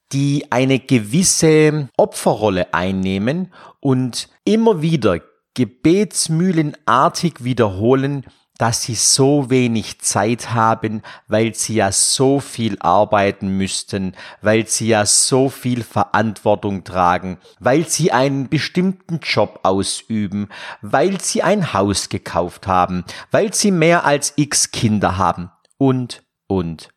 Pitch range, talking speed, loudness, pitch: 100-150 Hz, 115 wpm, -17 LUFS, 120 Hz